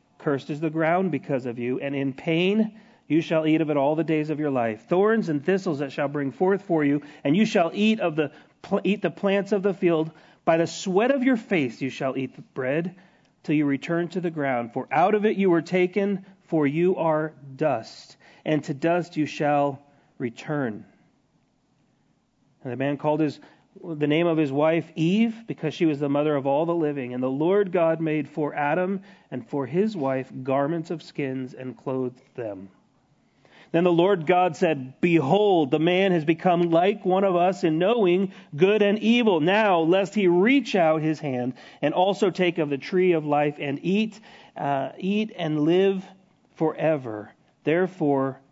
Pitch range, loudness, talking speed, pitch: 145-185 Hz, -24 LUFS, 190 wpm, 160 Hz